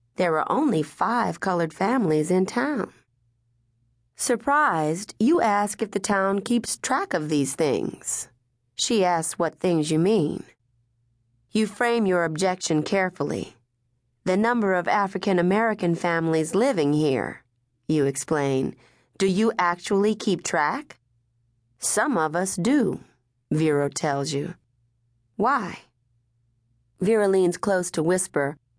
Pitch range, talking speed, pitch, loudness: 120-195 Hz, 120 wpm, 160 Hz, -24 LUFS